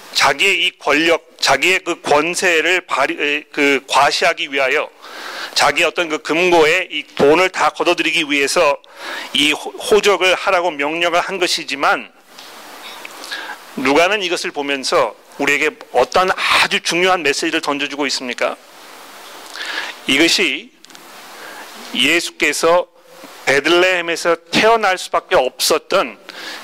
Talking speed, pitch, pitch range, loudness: 250 characters per minute, 170 Hz, 150-185 Hz, -15 LUFS